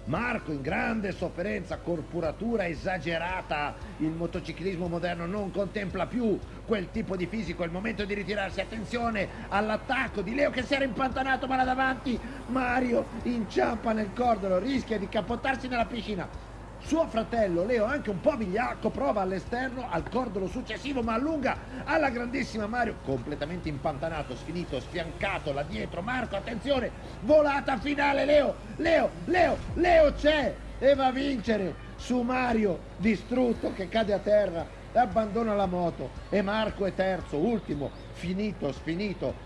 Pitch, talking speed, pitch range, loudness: 215 Hz, 140 wpm, 180-255 Hz, -29 LUFS